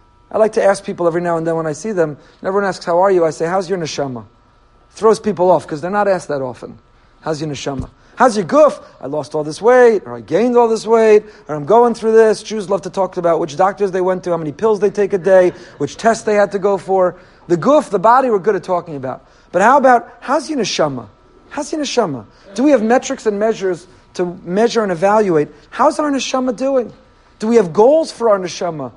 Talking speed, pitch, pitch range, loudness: 245 wpm, 195 Hz, 165-230 Hz, -15 LUFS